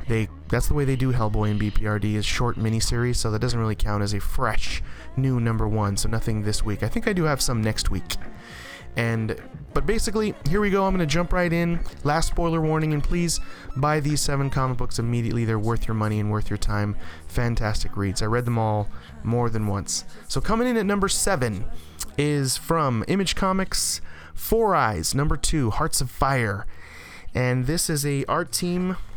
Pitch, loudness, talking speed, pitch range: 120 Hz, -24 LUFS, 200 wpm, 105-155 Hz